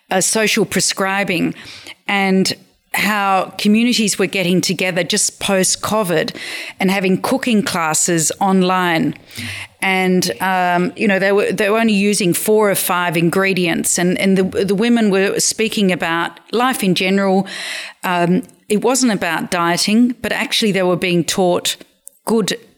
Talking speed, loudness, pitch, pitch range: 140 wpm, -16 LUFS, 190 Hz, 180-210 Hz